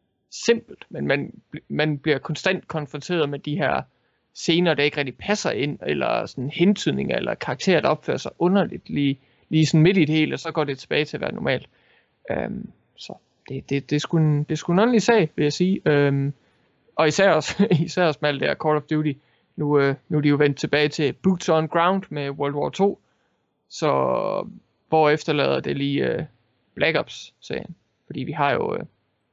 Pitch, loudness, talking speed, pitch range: 155 Hz, -22 LUFS, 200 wpm, 145-175 Hz